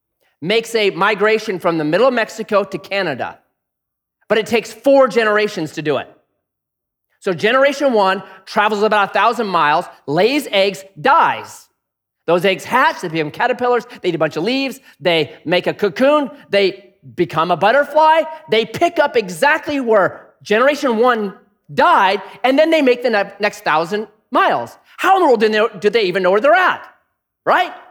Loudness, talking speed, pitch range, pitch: -16 LUFS, 165 wpm, 190-255 Hz, 210 Hz